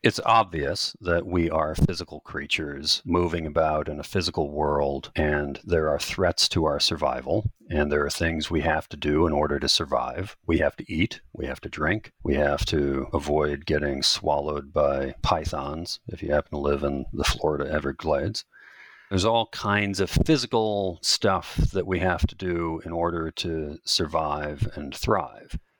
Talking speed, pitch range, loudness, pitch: 170 wpm, 75-90 Hz, -25 LUFS, 80 Hz